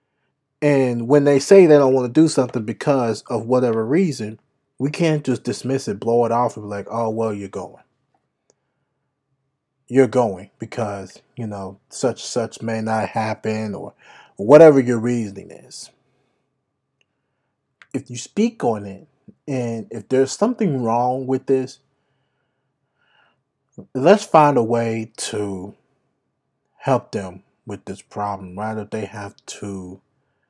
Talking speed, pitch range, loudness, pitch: 140 wpm, 110-140 Hz, -19 LUFS, 125 Hz